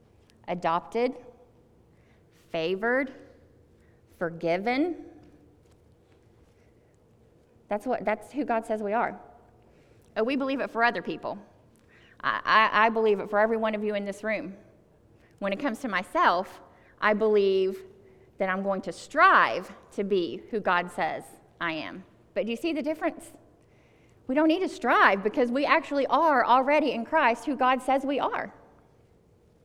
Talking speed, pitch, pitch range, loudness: 150 wpm, 220 Hz, 180-270 Hz, -26 LUFS